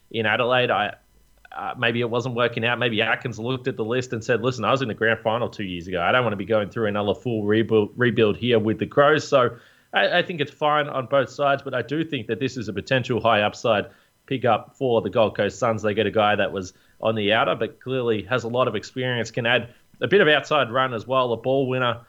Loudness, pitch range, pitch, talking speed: -22 LUFS, 110-130 Hz, 120 Hz, 265 wpm